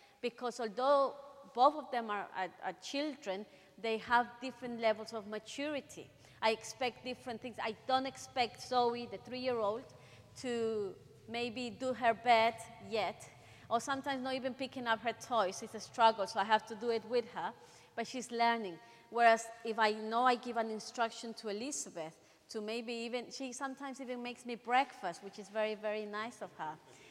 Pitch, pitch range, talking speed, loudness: 230 Hz, 215-250 Hz, 175 wpm, -36 LUFS